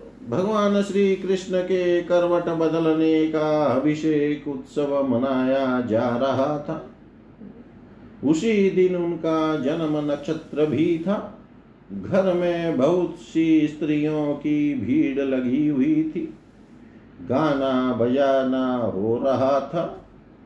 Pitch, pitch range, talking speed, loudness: 160 Hz, 145-190 Hz, 105 wpm, -22 LUFS